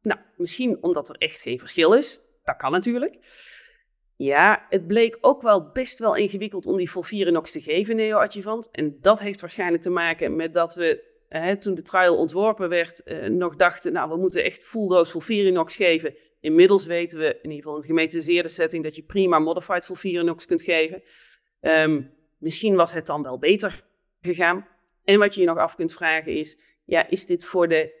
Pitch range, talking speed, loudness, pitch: 165-210 Hz, 190 wpm, -22 LUFS, 180 Hz